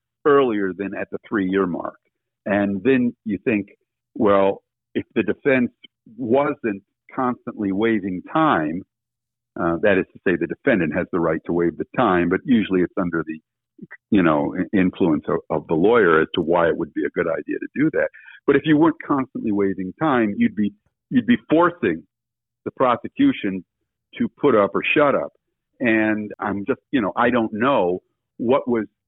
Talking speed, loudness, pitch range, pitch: 175 wpm, -21 LUFS, 95-135 Hz, 110 Hz